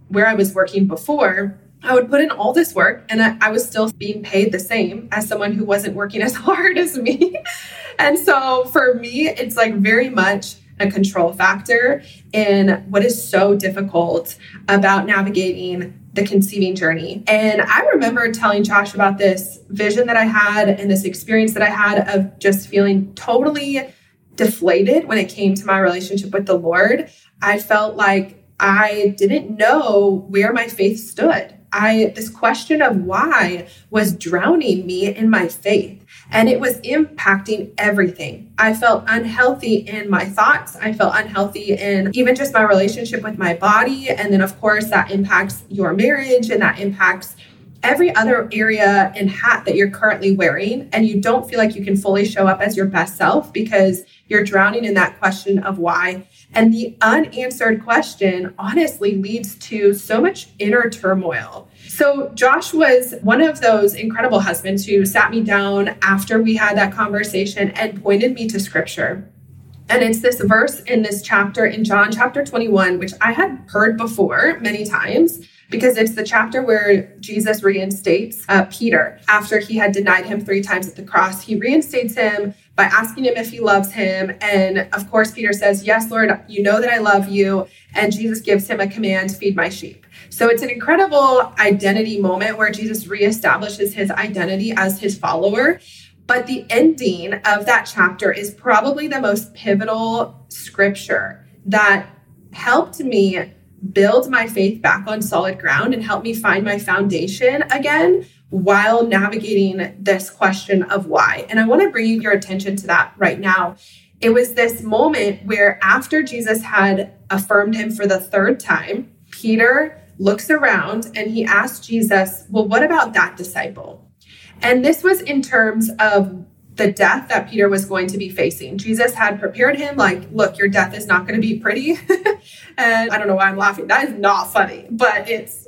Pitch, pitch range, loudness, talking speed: 210 Hz, 195-230 Hz, -16 LUFS, 175 wpm